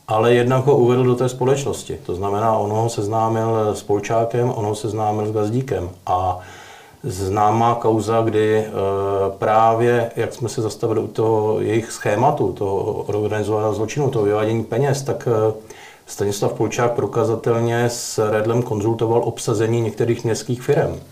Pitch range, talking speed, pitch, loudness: 110-120 Hz, 140 wpm, 115 Hz, -19 LUFS